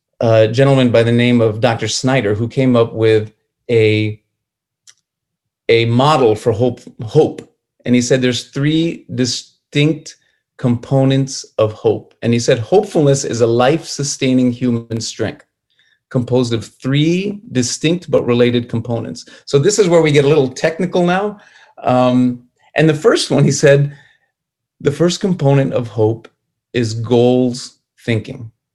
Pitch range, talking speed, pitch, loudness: 115-145 Hz, 145 wpm, 125 Hz, -15 LUFS